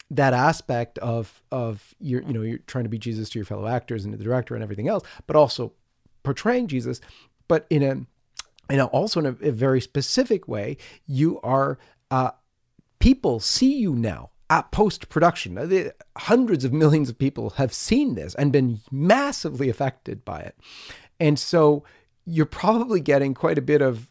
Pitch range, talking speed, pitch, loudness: 120-155 Hz, 185 wpm, 135 Hz, -23 LUFS